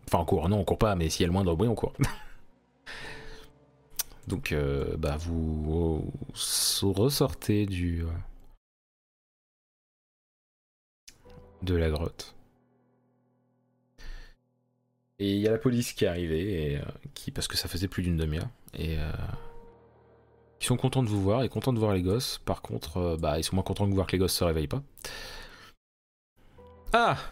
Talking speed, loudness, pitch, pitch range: 175 wpm, -29 LUFS, 100 Hz, 85-125 Hz